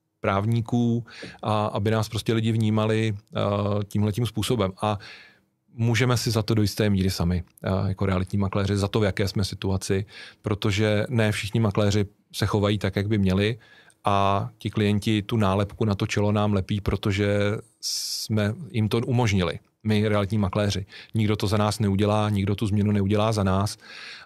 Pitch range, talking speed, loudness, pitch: 100-110 Hz, 165 wpm, -25 LUFS, 105 Hz